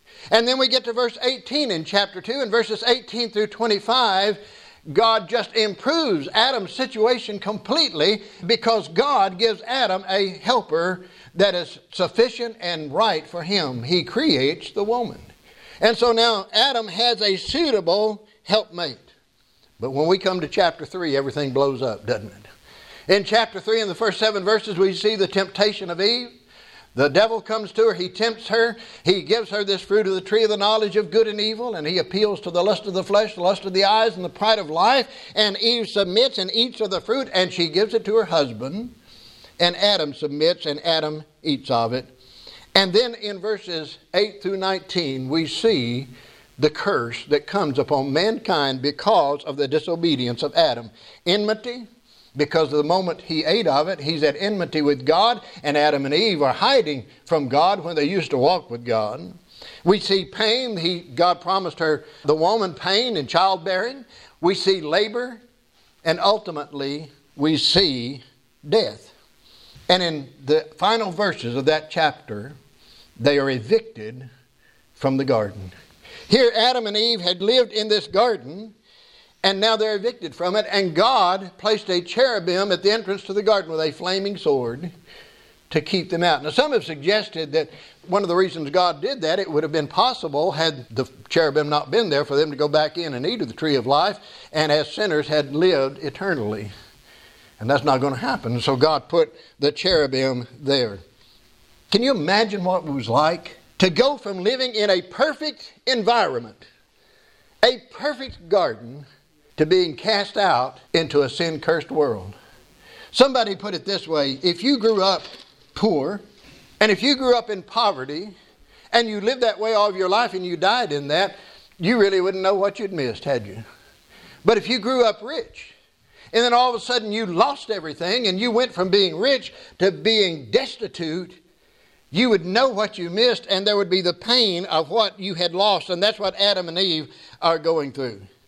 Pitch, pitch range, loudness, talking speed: 190 Hz, 155-220 Hz, -21 LUFS, 185 wpm